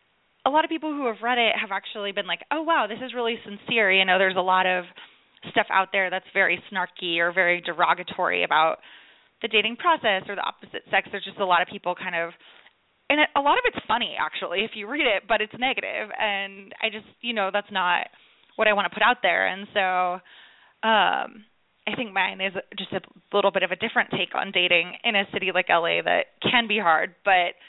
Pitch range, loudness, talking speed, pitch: 185-220 Hz, -23 LUFS, 225 wpm, 195 Hz